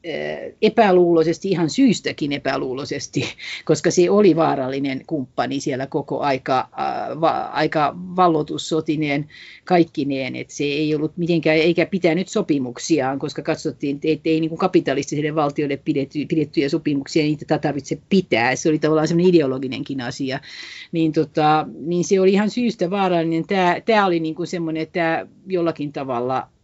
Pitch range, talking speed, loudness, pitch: 145-175 Hz, 135 wpm, -20 LUFS, 160 Hz